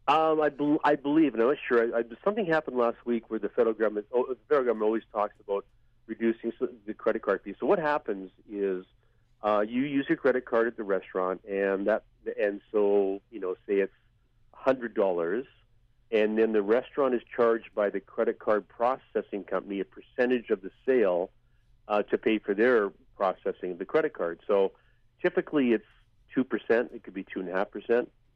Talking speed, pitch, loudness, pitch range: 205 wpm, 115 Hz, -28 LUFS, 105-125 Hz